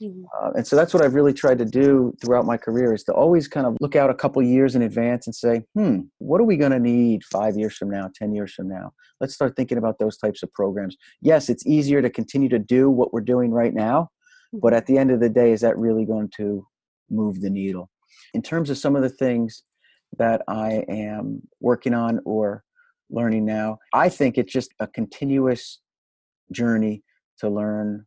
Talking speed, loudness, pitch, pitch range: 215 wpm, -21 LUFS, 120 Hz, 110-135 Hz